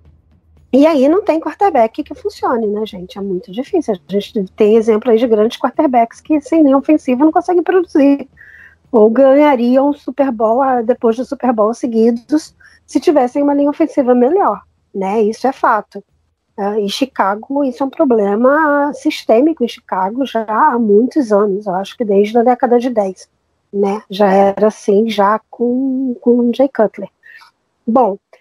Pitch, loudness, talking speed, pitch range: 245 Hz, -14 LUFS, 165 wpm, 210-285 Hz